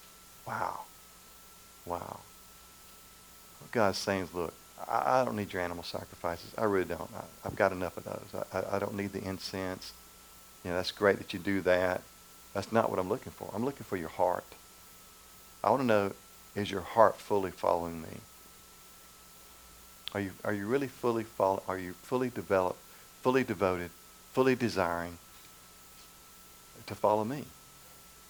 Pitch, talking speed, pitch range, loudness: 90 Hz, 155 wpm, 60-100 Hz, -32 LUFS